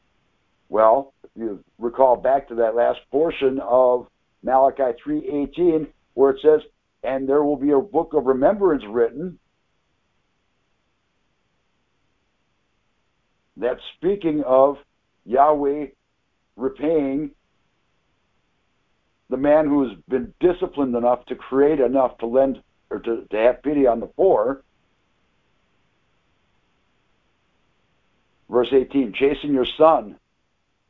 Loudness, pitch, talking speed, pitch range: -20 LUFS, 135 Hz, 105 wpm, 125-150 Hz